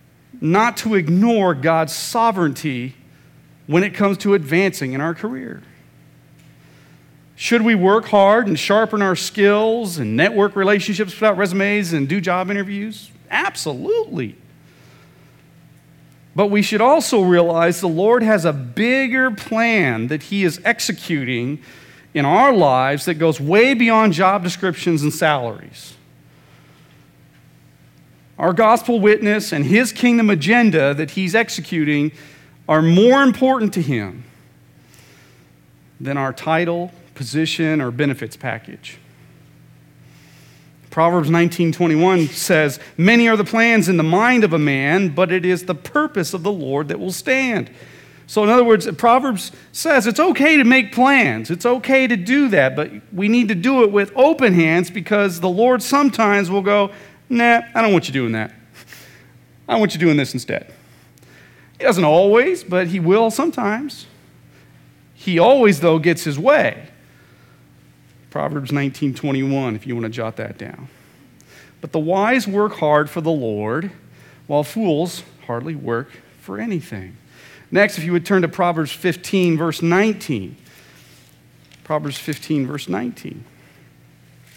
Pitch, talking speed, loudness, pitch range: 180 Hz, 140 wpm, -17 LUFS, 150-215 Hz